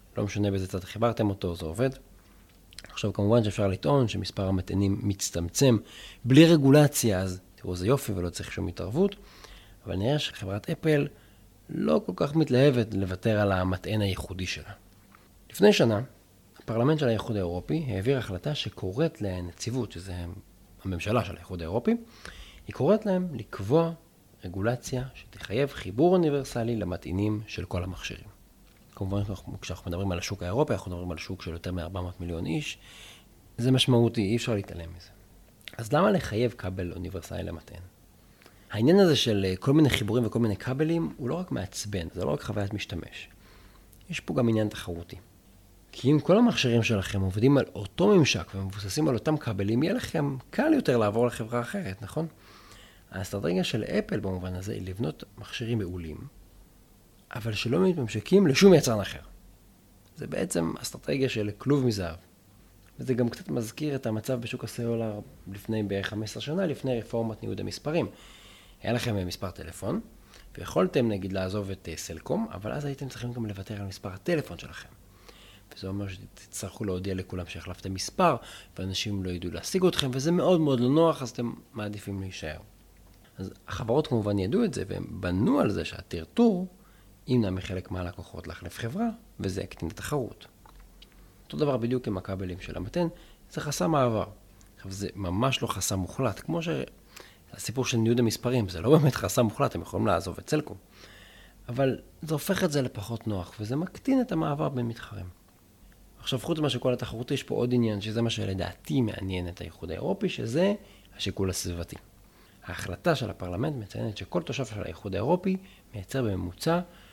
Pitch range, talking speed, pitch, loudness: 95-125 Hz, 160 wpm, 105 Hz, -28 LUFS